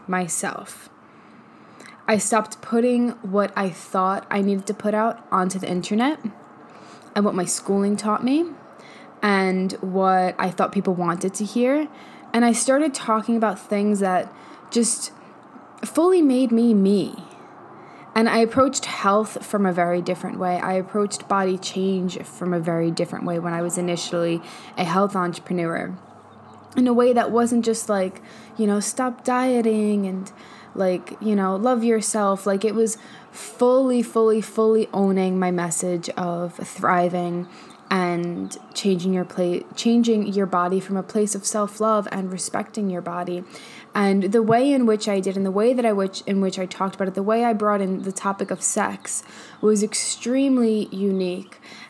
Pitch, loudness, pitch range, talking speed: 200 Hz, -22 LUFS, 185-225 Hz, 165 wpm